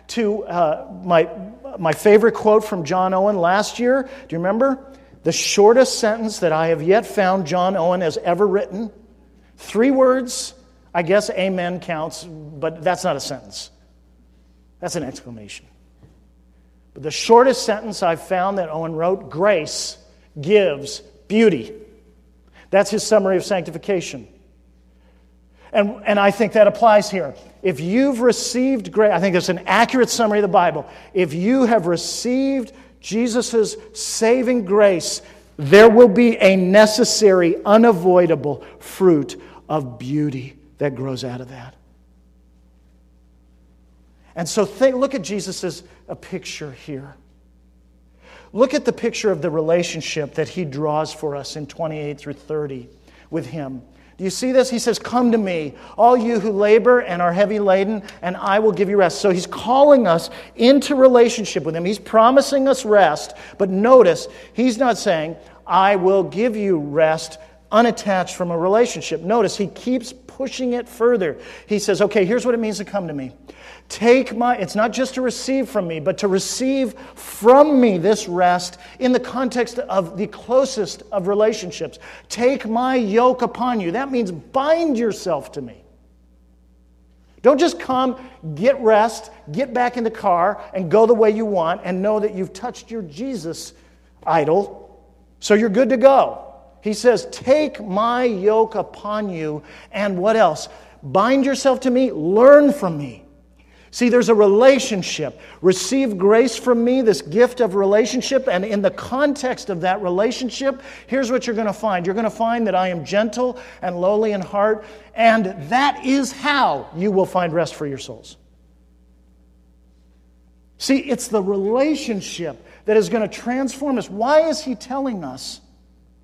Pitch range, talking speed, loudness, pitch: 165-235 Hz, 155 wpm, -18 LUFS, 205 Hz